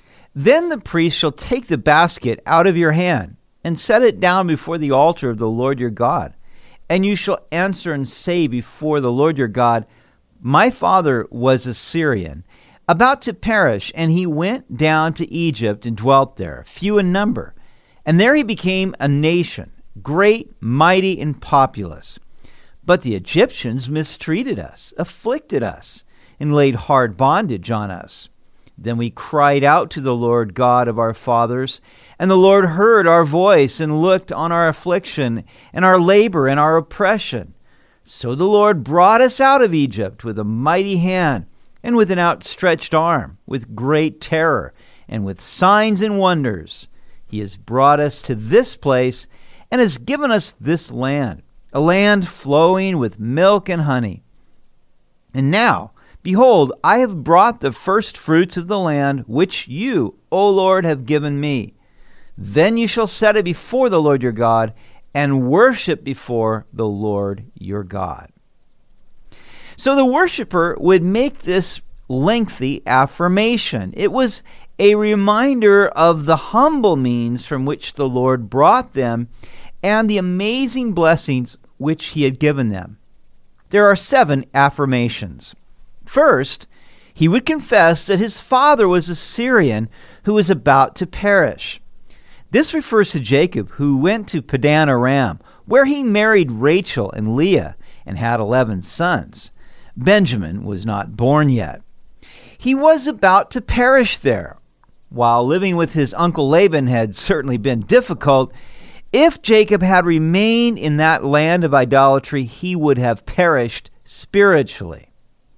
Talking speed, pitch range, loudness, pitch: 150 wpm, 125-195 Hz, -16 LUFS, 155 Hz